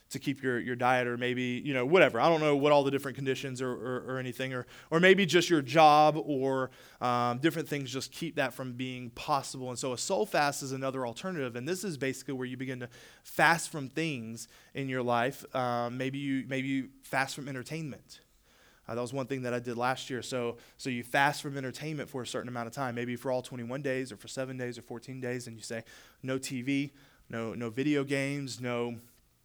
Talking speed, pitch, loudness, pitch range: 230 wpm, 130 Hz, -31 LUFS, 125-140 Hz